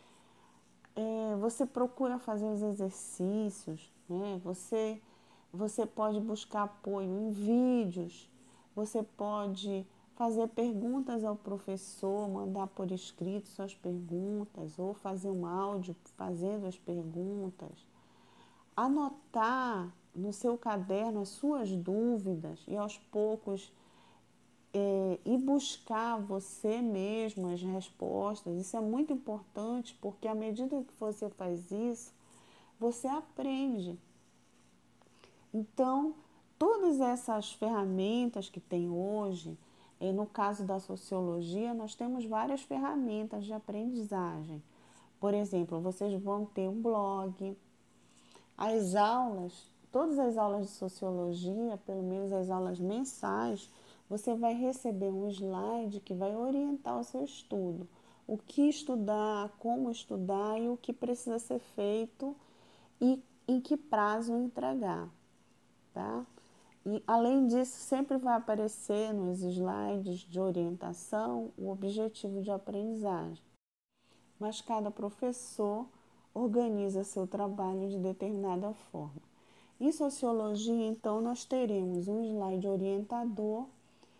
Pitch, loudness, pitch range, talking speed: 210 Hz, -36 LUFS, 190-230 Hz, 115 wpm